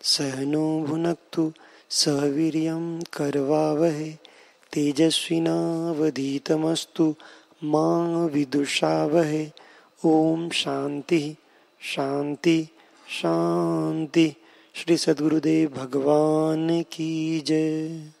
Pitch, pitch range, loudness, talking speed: 155 Hz, 145-160 Hz, -24 LUFS, 45 wpm